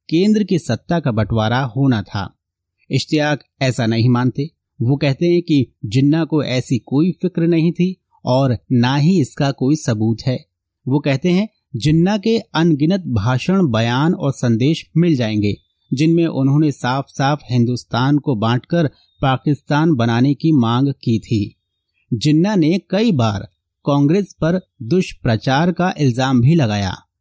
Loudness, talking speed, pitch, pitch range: -17 LUFS, 140 wpm, 135 Hz, 120-160 Hz